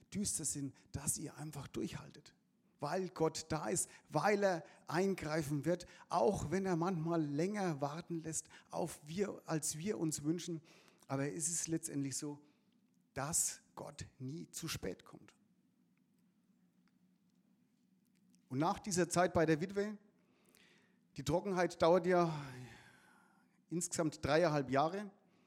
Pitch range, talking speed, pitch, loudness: 150-195 Hz, 125 wpm, 170 Hz, -38 LUFS